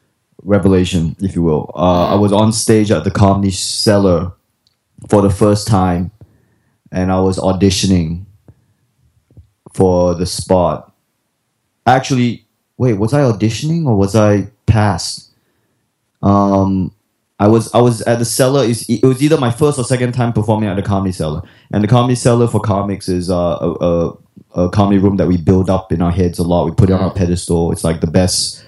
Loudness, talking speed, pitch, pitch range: -14 LUFS, 180 wpm, 100 Hz, 90-115 Hz